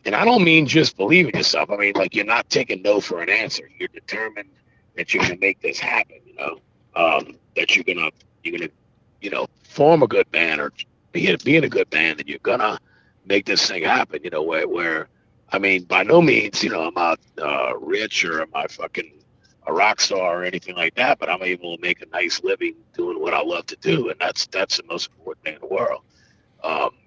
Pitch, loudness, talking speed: 330 Hz, -20 LUFS, 230 wpm